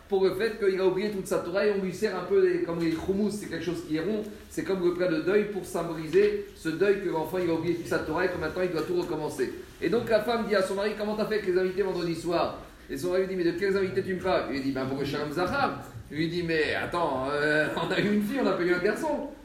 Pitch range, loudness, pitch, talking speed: 165-200 Hz, -28 LUFS, 185 Hz, 310 wpm